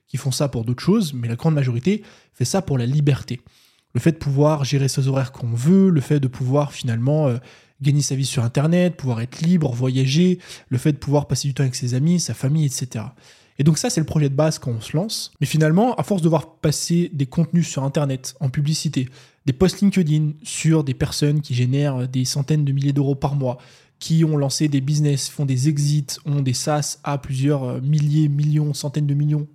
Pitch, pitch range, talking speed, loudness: 145 Hz, 135-155 Hz, 225 wpm, -20 LUFS